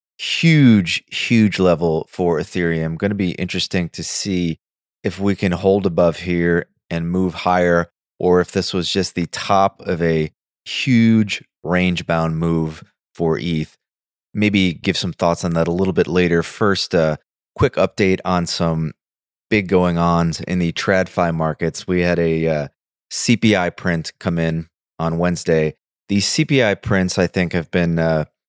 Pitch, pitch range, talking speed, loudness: 90 Hz, 85-95 Hz, 160 wpm, -18 LUFS